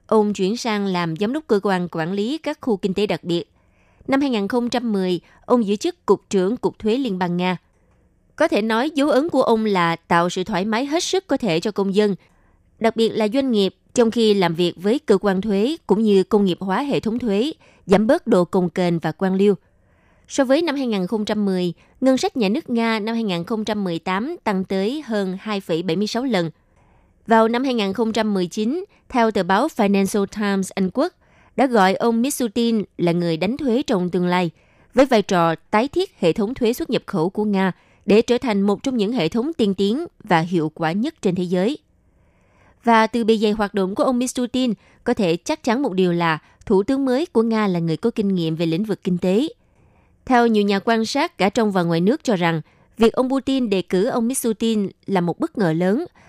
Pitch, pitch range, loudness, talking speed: 210 Hz, 185-235 Hz, -20 LUFS, 210 wpm